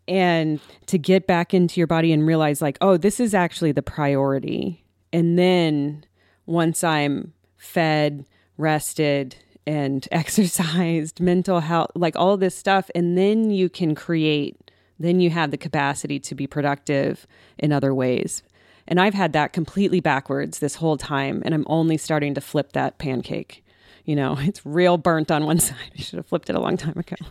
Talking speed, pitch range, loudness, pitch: 175 wpm, 145-180 Hz, -21 LUFS, 160 Hz